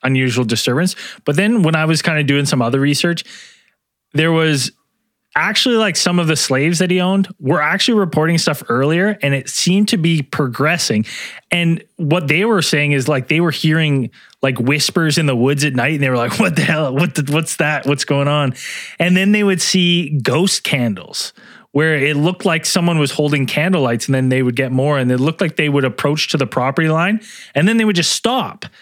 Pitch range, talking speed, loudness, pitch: 140-180 Hz, 220 wpm, -15 LUFS, 155 Hz